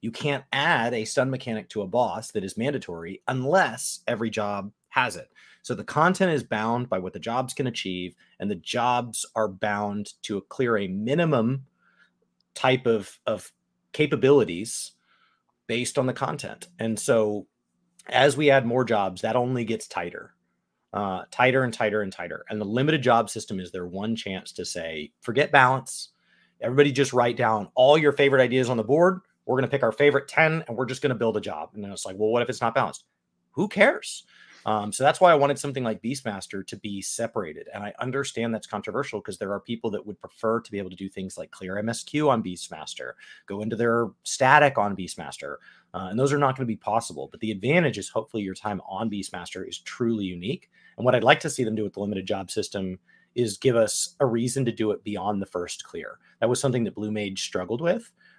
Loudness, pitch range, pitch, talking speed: -25 LUFS, 100-130 Hz, 115 Hz, 215 wpm